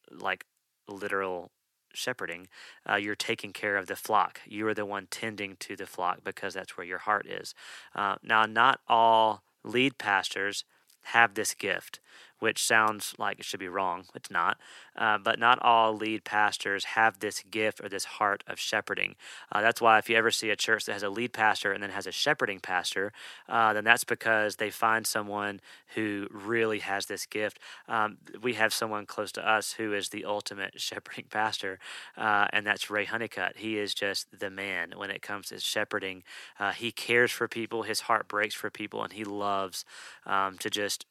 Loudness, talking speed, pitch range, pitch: -29 LUFS, 195 wpm, 100-110 Hz, 105 Hz